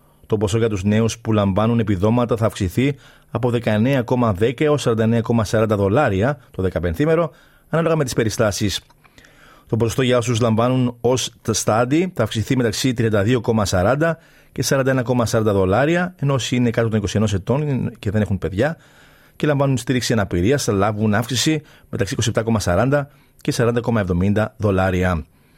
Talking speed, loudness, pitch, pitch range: 140 wpm, -19 LUFS, 115 Hz, 105-130 Hz